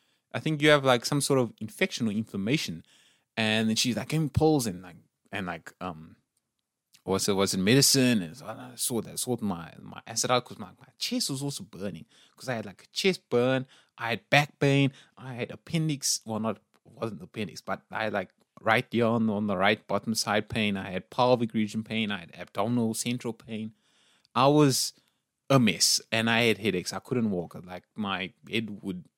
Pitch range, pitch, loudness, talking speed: 110-135 Hz, 115 Hz, -27 LUFS, 205 wpm